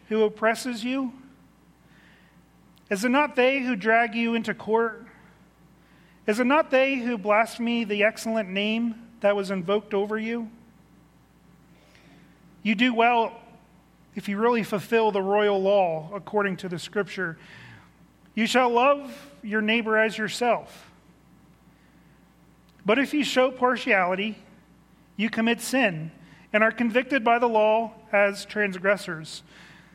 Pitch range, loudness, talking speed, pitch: 200-235 Hz, -24 LUFS, 125 wpm, 220 Hz